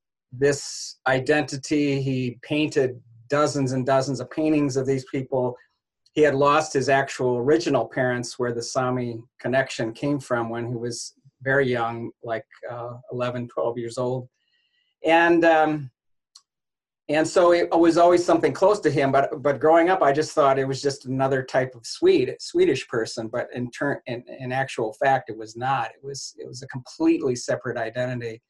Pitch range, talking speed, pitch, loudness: 125-155 Hz, 170 wpm, 135 Hz, -23 LUFS